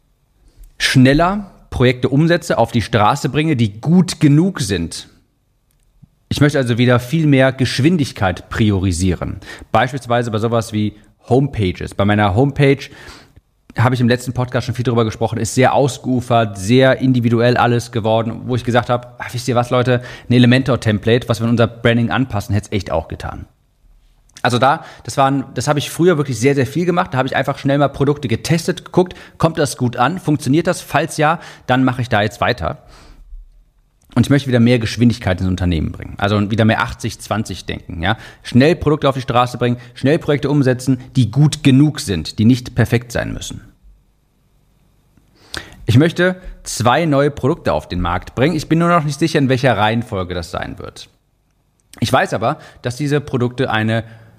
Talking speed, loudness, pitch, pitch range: 180 wpm, -16 LUFS, 125 Hz, 115-140 Hz